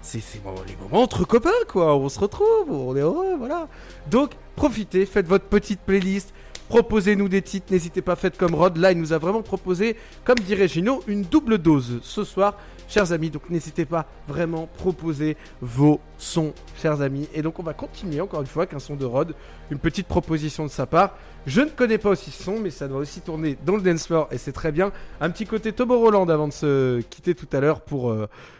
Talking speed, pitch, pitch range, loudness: 220 wpm, 175 Hz, 150-205 Hz, -23 LUFS